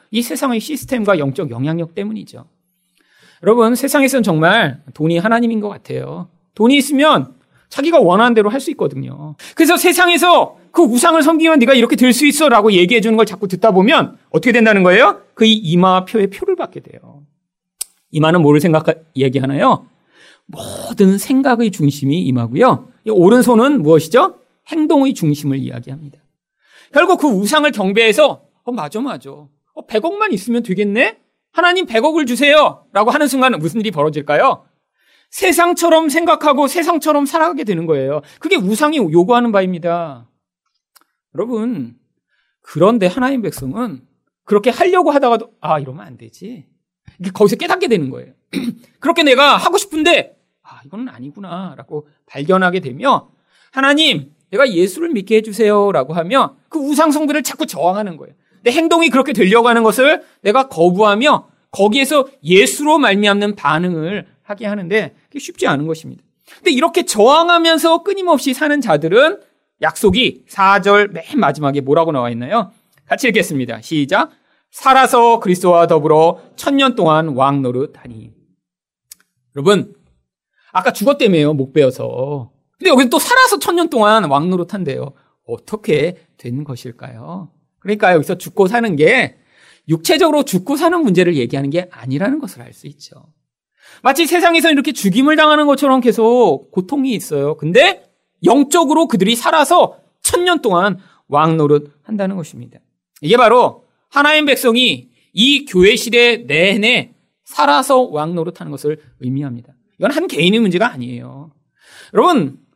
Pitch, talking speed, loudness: 215 Hz, 335 characters per minute, -13 LUFS